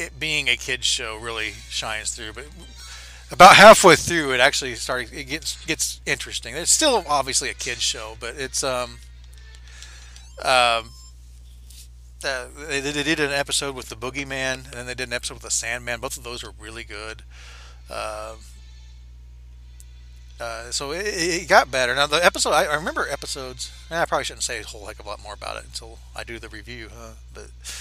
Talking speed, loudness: 190 wpm, -19 LUFS